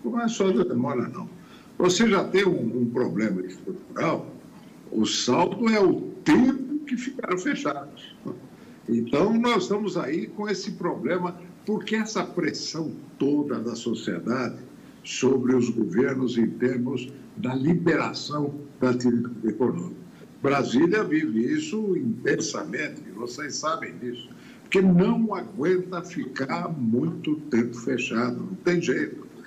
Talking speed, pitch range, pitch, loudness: 120 wpm, 125-205 Hz, 170 Hz, -25 LUFS